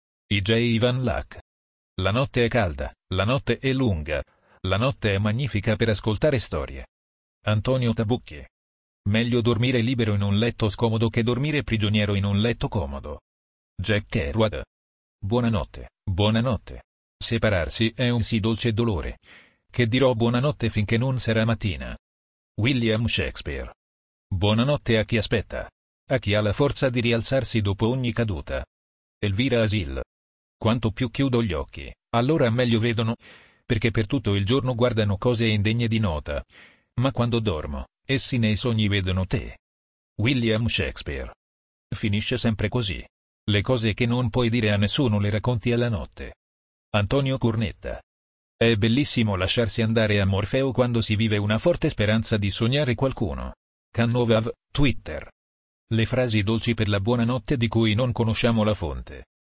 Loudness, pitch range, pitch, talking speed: -24 LUFS, 95-120 Hz, 110 Hz, 145 wpm